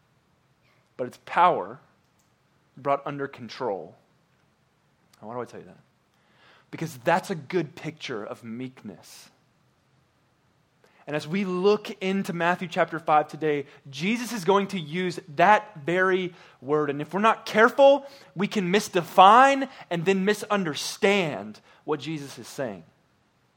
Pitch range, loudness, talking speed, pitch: 145-200 Hz, -24 LUFS, 130 wpm, 170 Hz